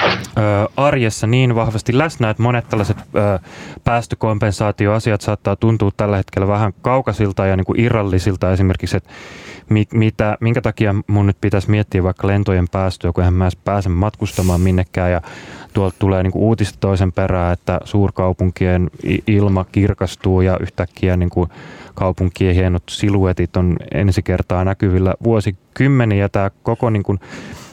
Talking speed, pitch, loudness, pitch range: 145 wpm, 100 Hz, -17 LUFS, 95-110 Hz